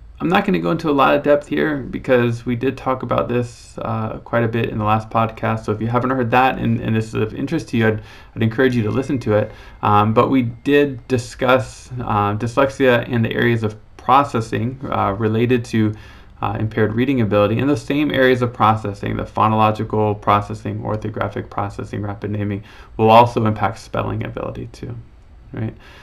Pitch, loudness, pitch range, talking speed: 115 Hz, -18 LUFS, 105-125 Hz, 200 wpm